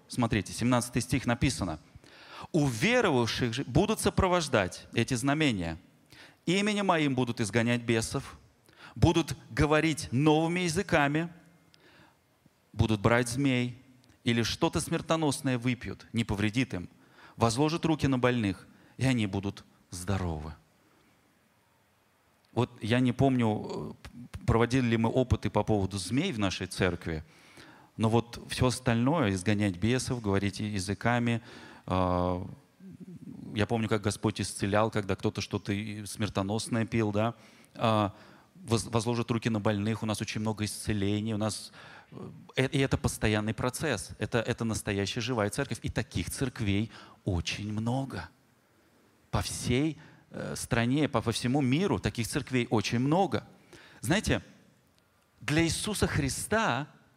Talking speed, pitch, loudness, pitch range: 115 wpm, 115 Hz, -30 LUFS, 105-130 Hz